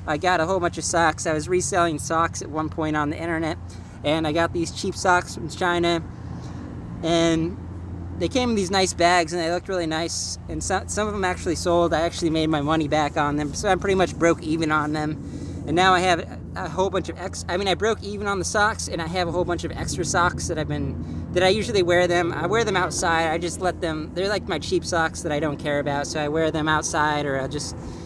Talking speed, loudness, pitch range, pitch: 260 wpm, -23 LUFS, 150-180 Hz, 165 Hz